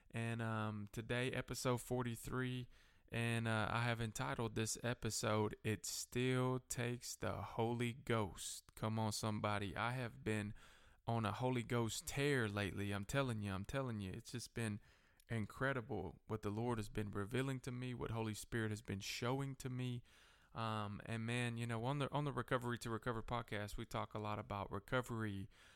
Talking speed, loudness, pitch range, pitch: 175 wpm, -43 LUFS, 105-125 Hz, 115 Hz